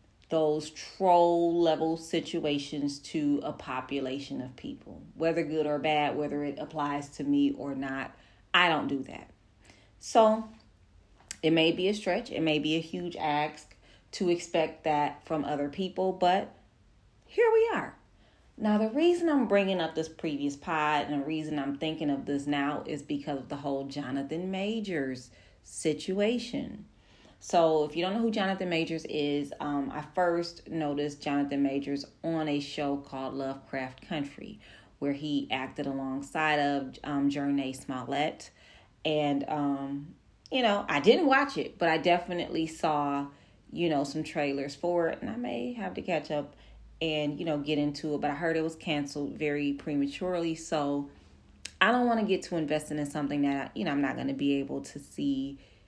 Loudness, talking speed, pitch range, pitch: -30 LUFS, 175 wpm, 140-165 Hz, 150 Hz